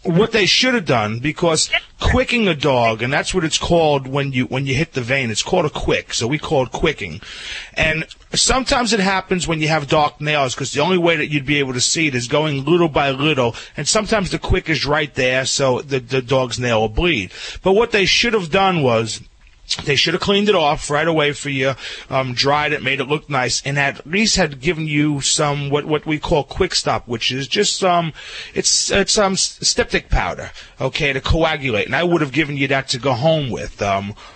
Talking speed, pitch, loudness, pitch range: 230 wpm, 150 Hz, -17 LUFS, 130-170 Hz